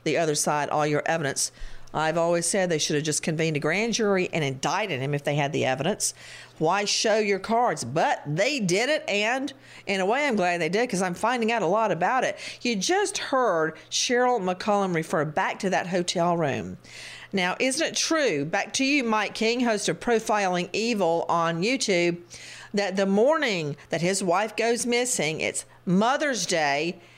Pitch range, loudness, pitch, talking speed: 160-225 Hz, -25 LUFS, 185 Hz, 190 wpm